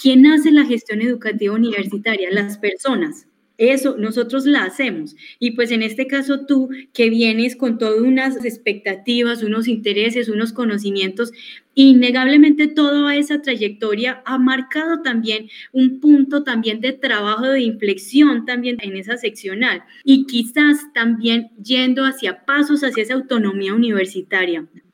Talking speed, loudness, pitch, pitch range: 135 wpm, -17 LUFS, 245 Hz, 220-270 Hz